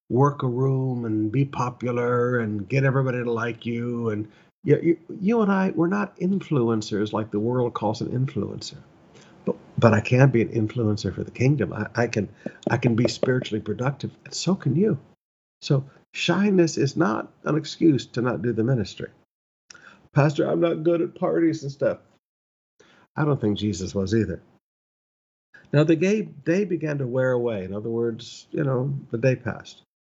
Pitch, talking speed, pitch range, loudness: 125 Hz, 180 wpm, 110-155 Hz, -24 LUFS